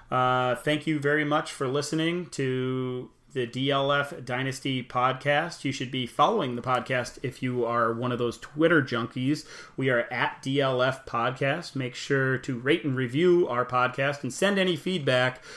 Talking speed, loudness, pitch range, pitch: 165 wpm, -27 LUFS, 125-145 Hz, 130 Hz